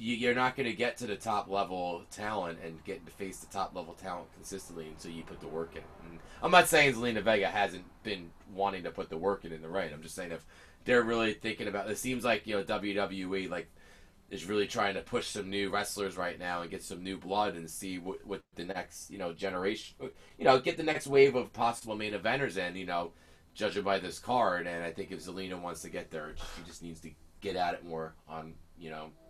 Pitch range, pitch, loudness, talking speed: 85-105 Hz, 95 Hz, -33 LUFS, 240 wpm